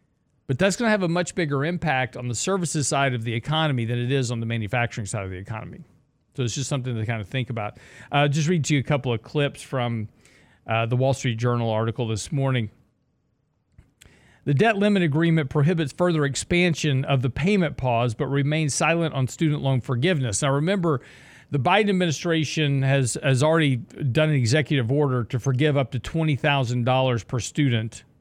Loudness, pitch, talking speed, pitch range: -23 LUFS, 135 Hz, 195 wpm, 120-155 Hz